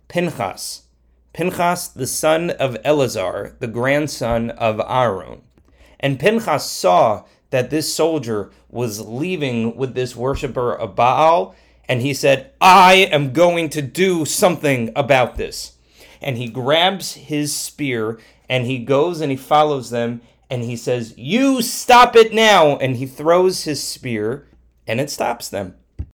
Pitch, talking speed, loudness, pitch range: 140 Hz, 140 wpm, -17 LUFS, 120-165 Hz